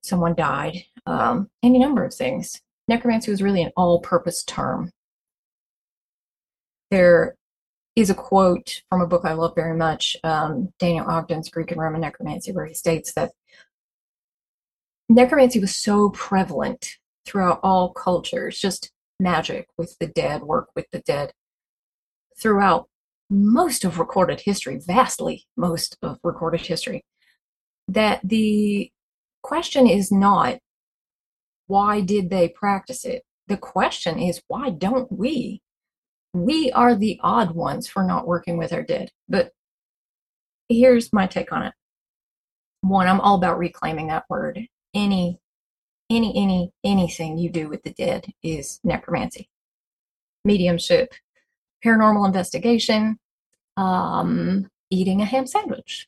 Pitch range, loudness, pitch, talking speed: 175-235 Hz, -21 LUFS, 195 Hz, 130 wpm